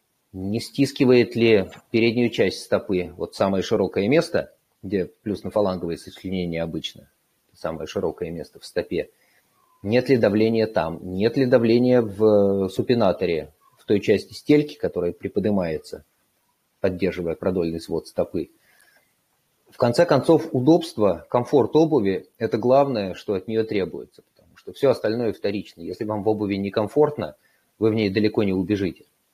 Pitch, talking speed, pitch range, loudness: 110 Hz, 140 wpm, 100-125 Hz, -22 LUFS